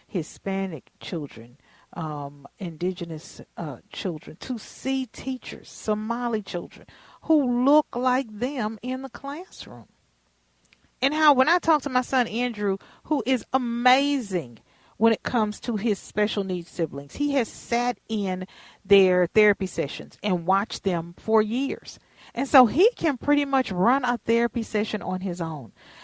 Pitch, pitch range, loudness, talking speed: 220 Hz, 185-255 Hz, -25 LUFS, 145 wpm